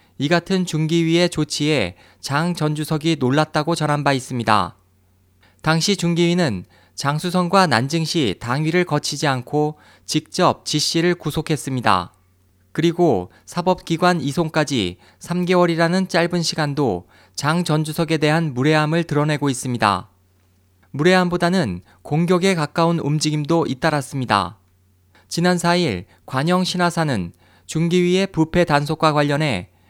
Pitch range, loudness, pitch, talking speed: 105-170 Hz, -19 LUFS, 155 Hz, 285 characters per minute